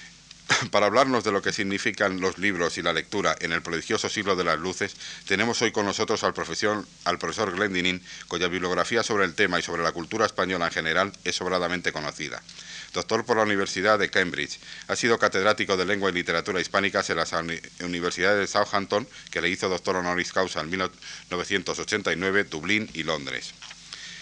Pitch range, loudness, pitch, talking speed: 85-100 Hz, -25 LUFS, 95 Hz, 175 wpm